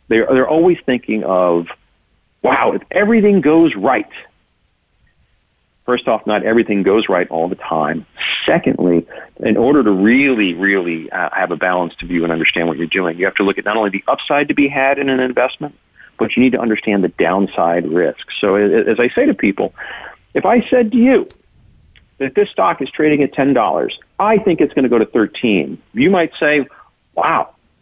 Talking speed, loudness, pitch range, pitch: 190 wpm, -15 LUFS, 90-150 Hz, 115 Hz